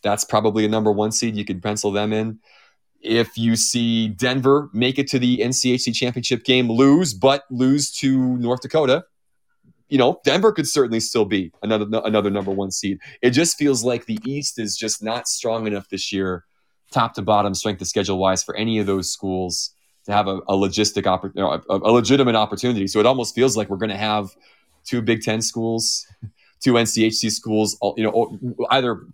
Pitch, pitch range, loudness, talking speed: 110 Hz, 105-125 Hz, -20 LUFS, 200 wpm